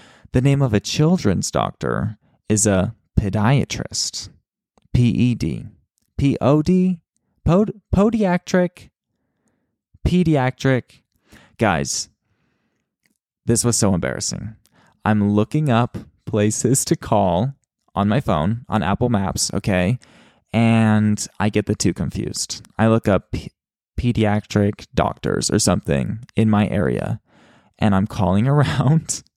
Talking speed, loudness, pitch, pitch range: 110 wpm, -19 LUFS, 110 Hz, 105-135 Hz